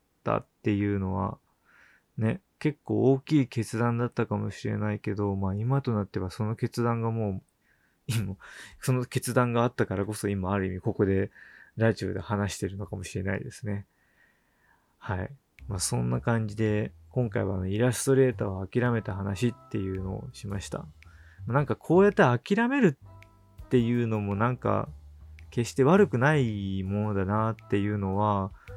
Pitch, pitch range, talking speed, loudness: 105 Hz, 100-120 Hz, 320 characters per minute, -28 LUFS